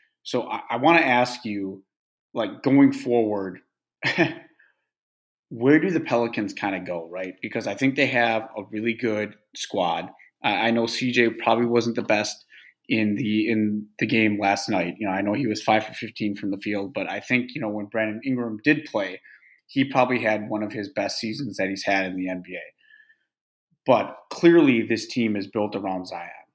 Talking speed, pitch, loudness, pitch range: 195 wpm, 110 Hz, -23 LUFS, 105-125 Hz